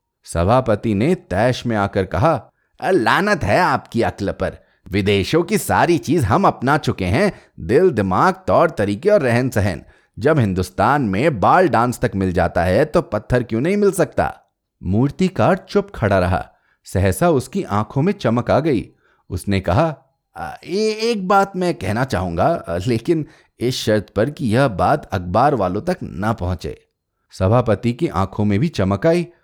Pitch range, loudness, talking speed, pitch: 100-165 Hz, -18 LUFS, 165 wpm, 120 Hz